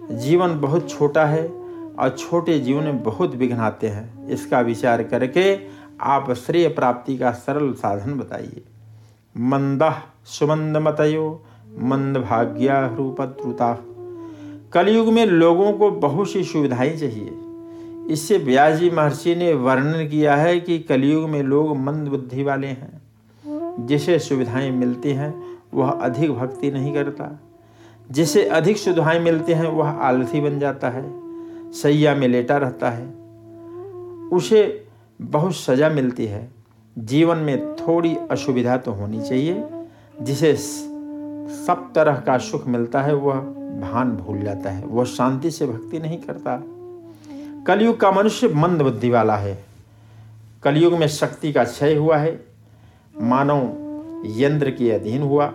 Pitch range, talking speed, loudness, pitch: 125-170 Hz, 135 wpm, -20 LUFS, 145 Hz